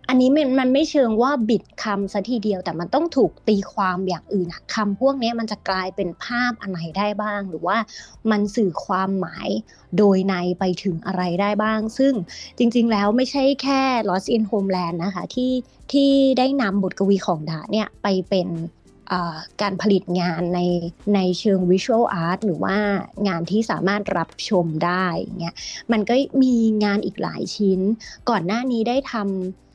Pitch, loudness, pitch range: 200 Hz, -21 LUFS, 185-230 Hz